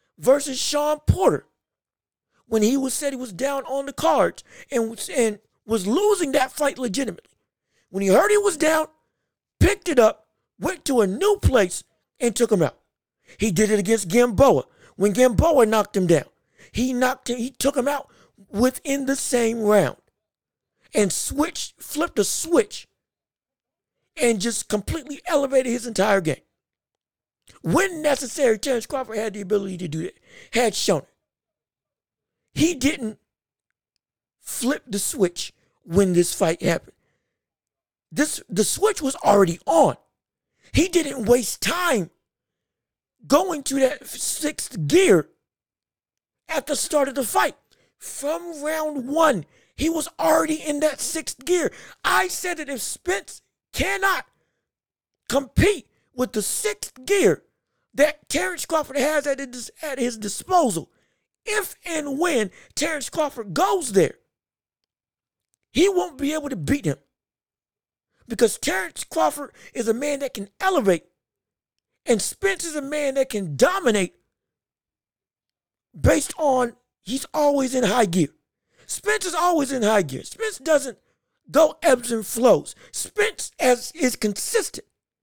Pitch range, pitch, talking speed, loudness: 225-315 Hz, 275 Hz, 140 wpm, -22 LUFS